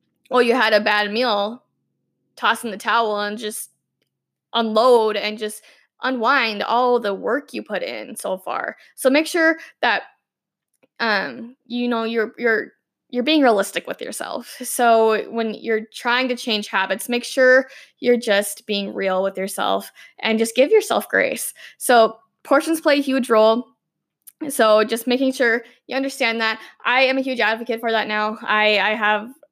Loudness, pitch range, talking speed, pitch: -19 LUFS, 215-255 Hz, 165 wpm, 230 Hz